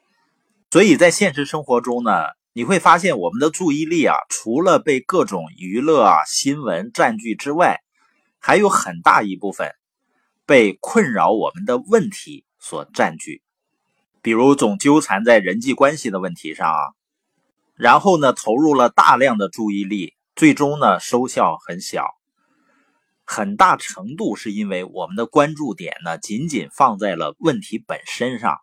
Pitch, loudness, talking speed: 145 Hz, -17 LUFS, 230 characters per minute